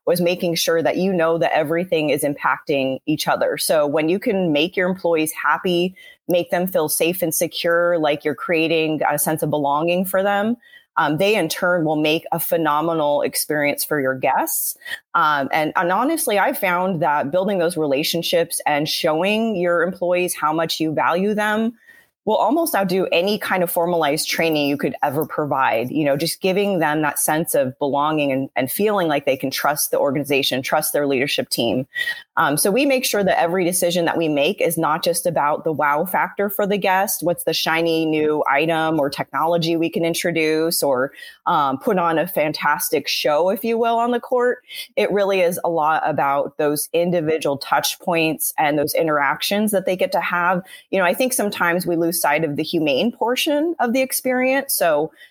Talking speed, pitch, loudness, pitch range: 195 wpm, 170 Hz, -19 LUFS, 155-200 Hz